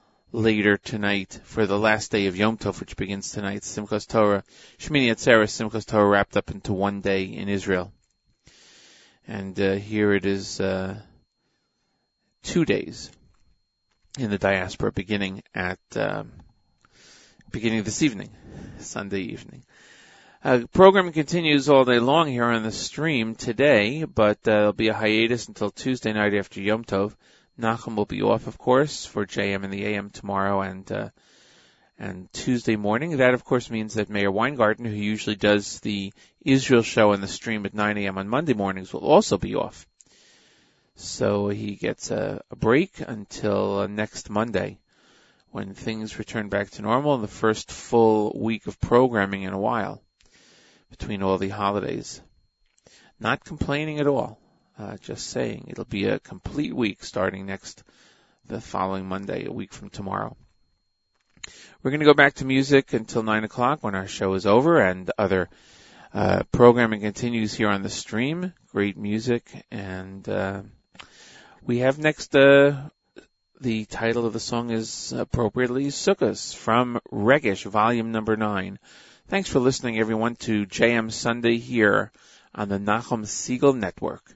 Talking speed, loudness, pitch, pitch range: 155 wpm, -23 LUFS, 110 Hz, 100-120 Hz